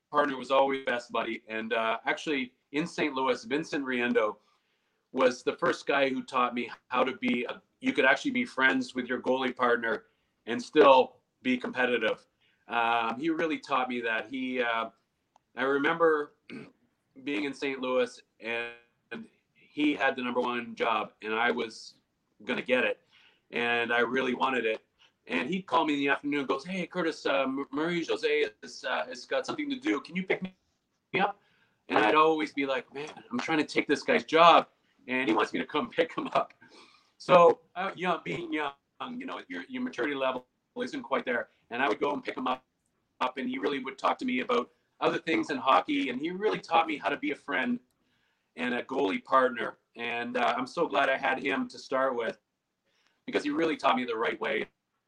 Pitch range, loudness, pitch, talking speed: 125-165 Hz, -29 LUFS, 135 Hz, 200 wpm